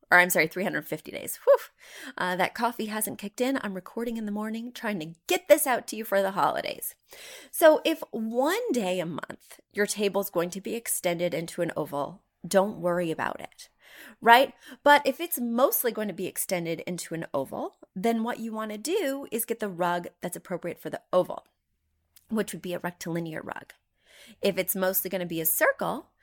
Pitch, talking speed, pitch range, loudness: 205 Hz, 200 wpm, 175-240 Hz, -27 LUFS